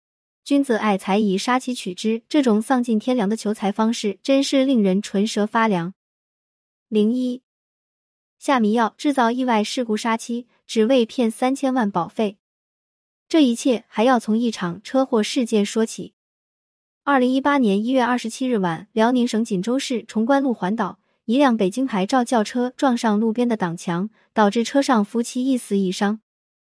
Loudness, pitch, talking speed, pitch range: -21 LUFS, 230 Hz, 250 characters per minute, 210-255 Hz